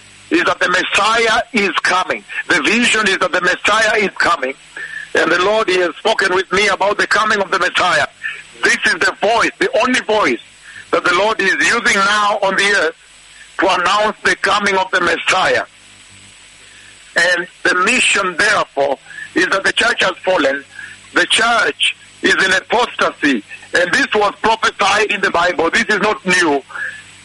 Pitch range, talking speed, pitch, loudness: 190-230 Hz, 170 wpm, 210 Hz, -14 LUFS